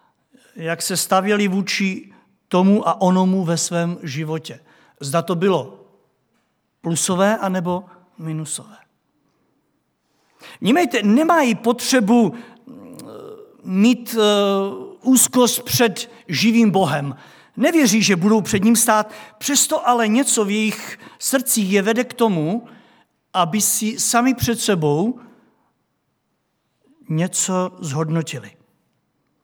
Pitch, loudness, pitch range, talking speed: 210 Hz, -18 LUFS, 180-235 Hz, 100 wpm